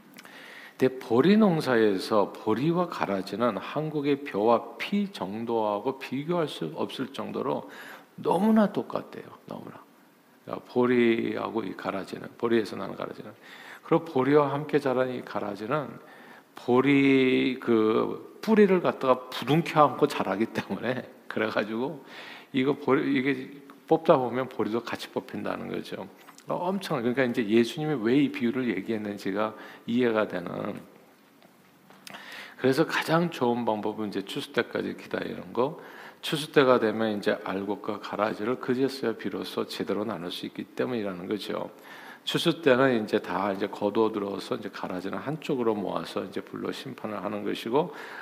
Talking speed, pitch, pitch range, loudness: 310 characters per minute, 125 Hz, 110-150 Hz, -27 LUFS